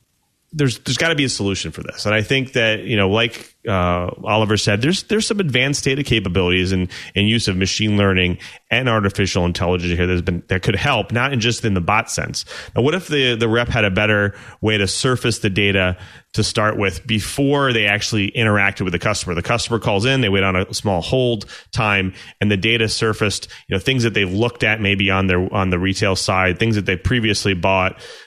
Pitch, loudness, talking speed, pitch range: 105 Hz, -18 LUFS, 225 wpm, 95-120 Hz